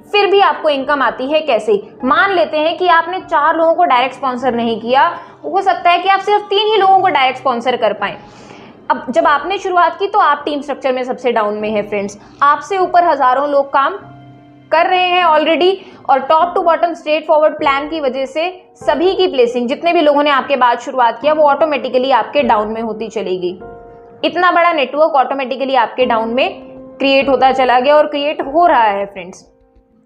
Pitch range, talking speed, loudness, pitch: 245-330 Hz, 190 wpm, -13 LUFS, 285 Hz